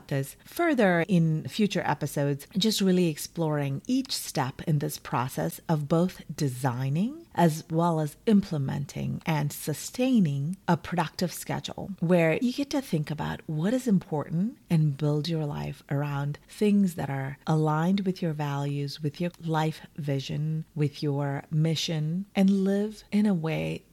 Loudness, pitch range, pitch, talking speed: -28 LUFS, 145-185 Hz, 160 Hz, 145 wpm